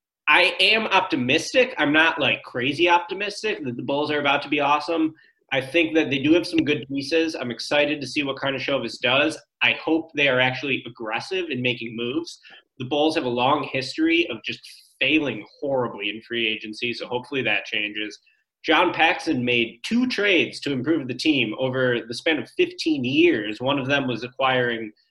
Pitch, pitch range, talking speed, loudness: 140 Hz, 125-165 Hz, 190 wpm, -22 LUFS